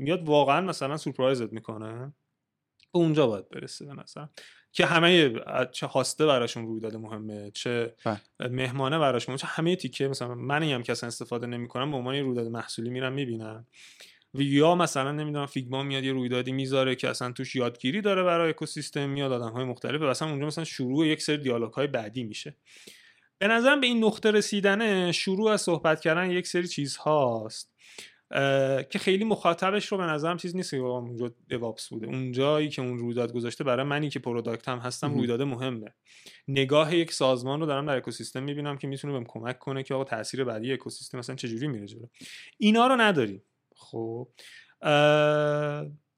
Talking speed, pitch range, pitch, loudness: 170 wpm, 120-155 Hz, 135 Hz, -27 LUFS